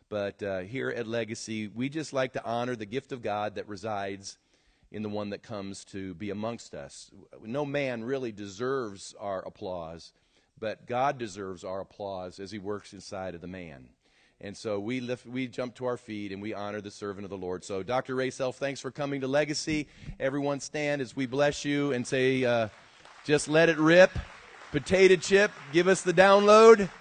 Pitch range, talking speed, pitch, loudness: 100-145 Hz, 195 wpm, 120 Hz, -28 LUFS